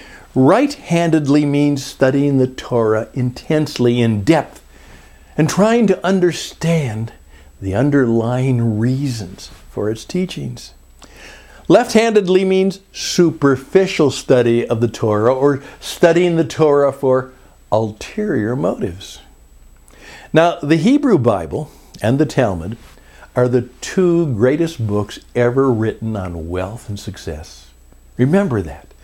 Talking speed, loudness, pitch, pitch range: 105 wpm, -16 LUFS, 130 Hz, 105-160 Hz